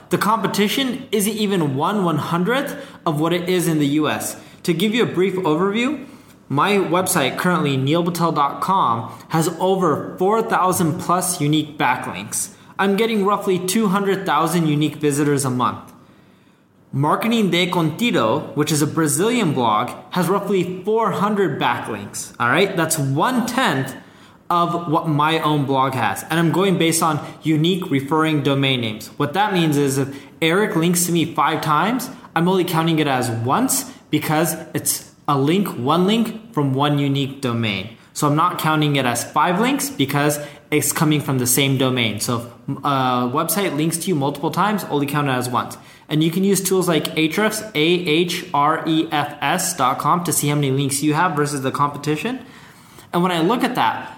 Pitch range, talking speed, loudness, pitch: 145-185 Hz, 165 wpm, -19 LUFS, 160 Hz